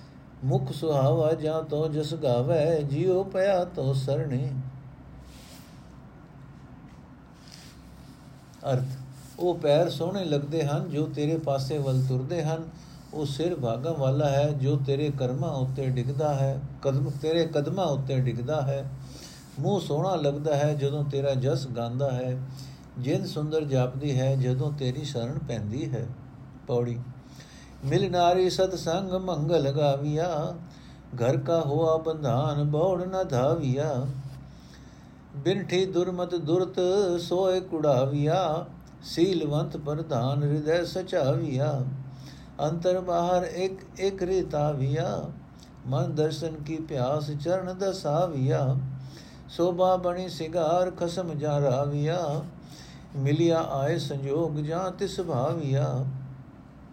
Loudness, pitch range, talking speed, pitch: -27 LUFS, 135-170 Hz, 105 wpm, 150 Hz